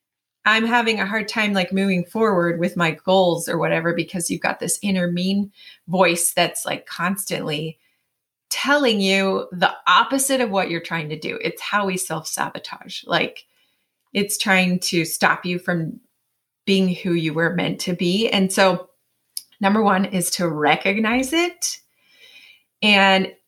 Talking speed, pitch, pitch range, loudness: 155 wpm, 185 Hz, 170-205 Hz, -20 LUFS